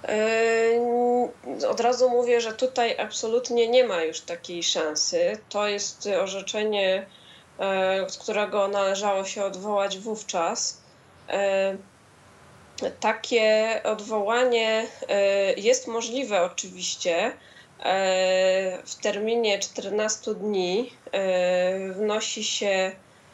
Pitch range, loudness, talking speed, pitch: 195-230 Hz, -25 LUFS, 80 wpm, 210 Hz